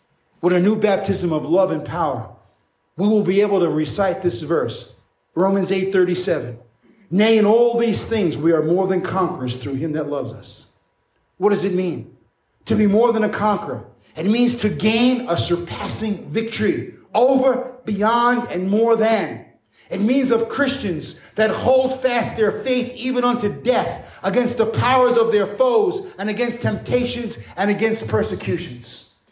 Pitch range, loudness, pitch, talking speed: 180-235 Hz, -19 LUFS, 210 Hz, 165 wpm